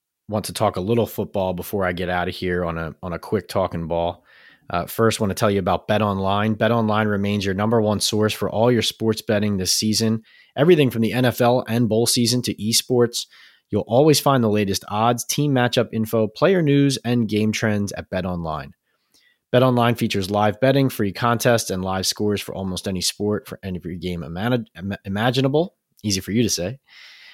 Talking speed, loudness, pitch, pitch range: 210 wpm, -21 LUFS, 105 Hz, 95-120 Hz